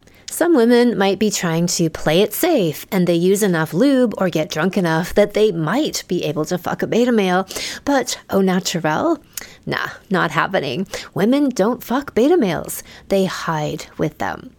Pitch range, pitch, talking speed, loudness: 170-230 Hz, 190 Hz, 175 wpm, -18 LUFS